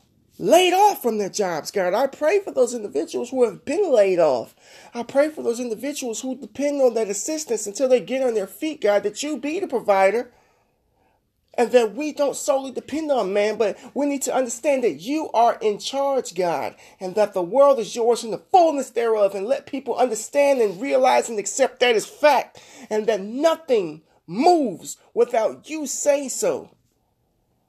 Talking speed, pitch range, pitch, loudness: 185 wpm, 220-290 Hz, 255 Hz, -21 LUFS